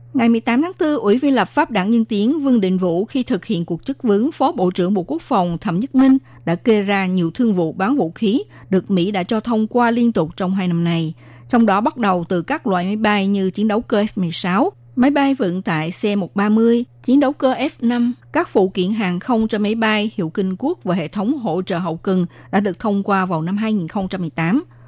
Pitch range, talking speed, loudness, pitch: 185-240 Hz, 235 wpm, -18 LUFS, 205 Hz